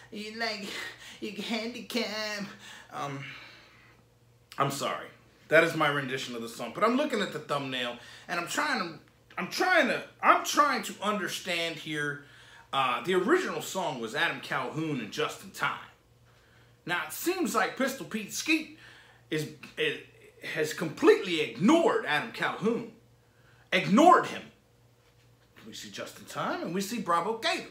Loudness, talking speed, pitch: -29 LUFS, 145 wpm, 205 Hz